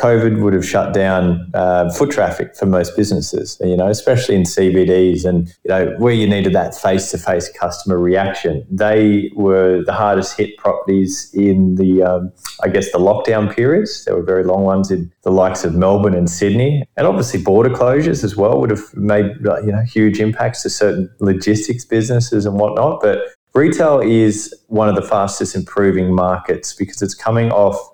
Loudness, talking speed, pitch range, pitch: -15 LUFS, 180 wpm, 90-105 Hz, 95 Hz